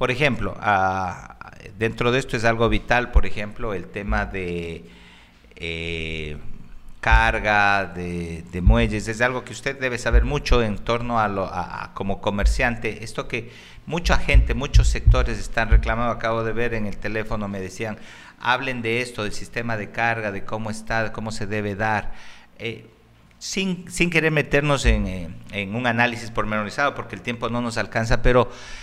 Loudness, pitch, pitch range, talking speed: -23 LUFS, 110 Hz, 100-120 Hz, 170 wpm